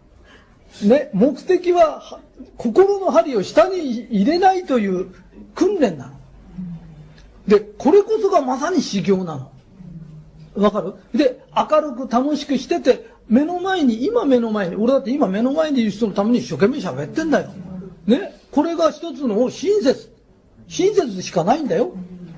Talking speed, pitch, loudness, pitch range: 270 characters per minute, 245 Hz, -19 LUFS, 195-310 Hz